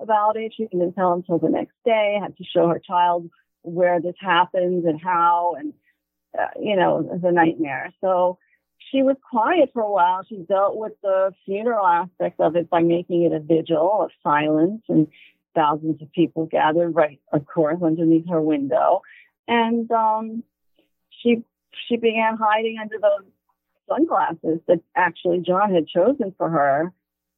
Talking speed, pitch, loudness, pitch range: 160 wpm, 180 Hz, -21 LUFS, 165-220 Hz